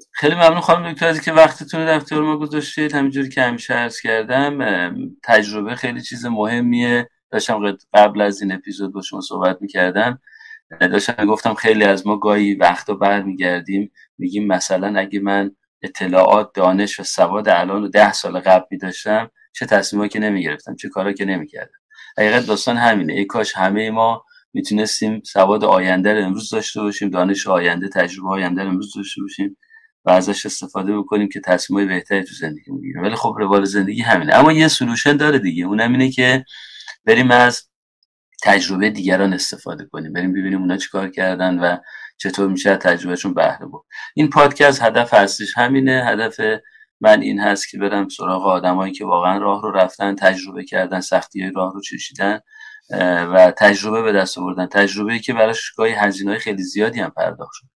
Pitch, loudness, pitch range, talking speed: 105 Hz, -17 LUFS, 95-130 Hz, 170 wpm